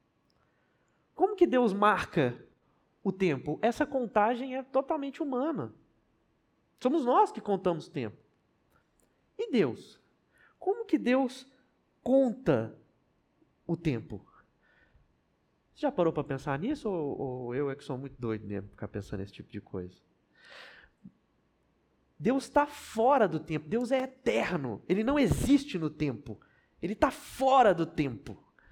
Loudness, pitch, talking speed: -30 LUFS, 195 Hz, 130 wpm